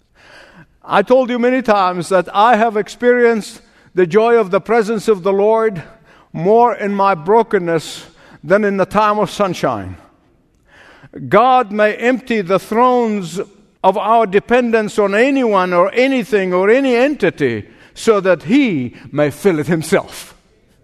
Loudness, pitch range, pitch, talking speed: -14 LUFS, 190-235 Hz, 210 Hz, 140 wpm